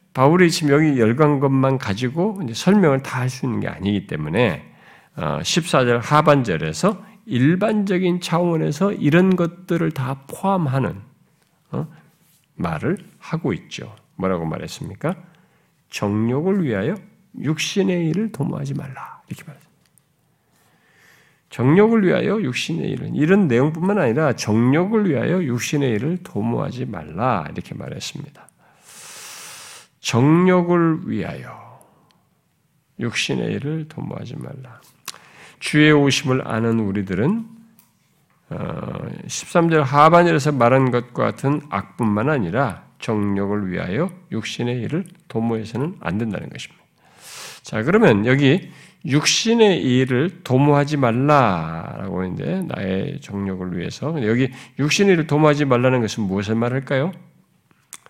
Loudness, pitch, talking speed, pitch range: -19 LUFS, 150 Hz, 270 characters per minute, 125-175 Hz